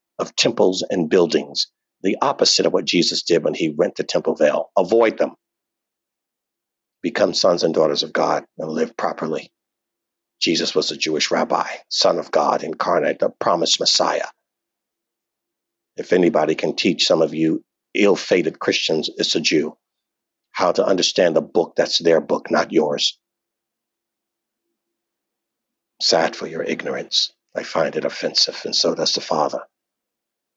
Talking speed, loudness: 150 wpm, -19 LUFS